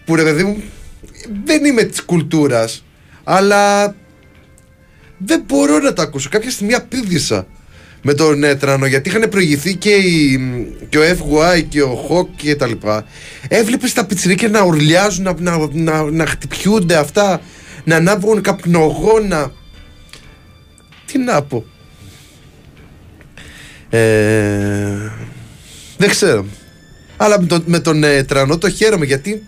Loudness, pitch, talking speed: -14 LUFS, 155 Hz, 125 wpm